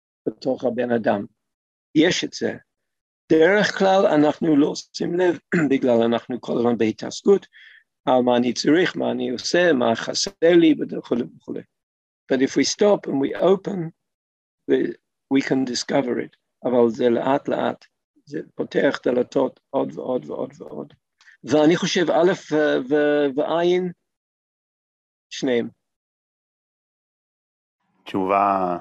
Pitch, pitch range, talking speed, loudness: 145 Hz, 120-175 Hz, 115 wpm, -21 LUFS